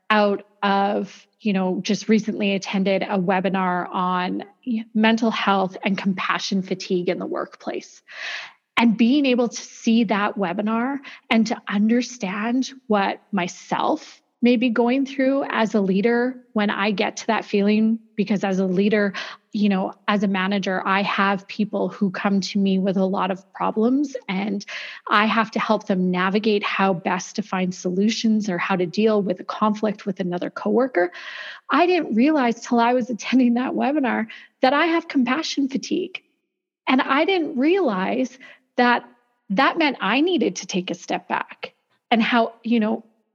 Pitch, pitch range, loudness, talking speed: 215 Hz, 195-245 Hz, -22 LUFS, 160 wpm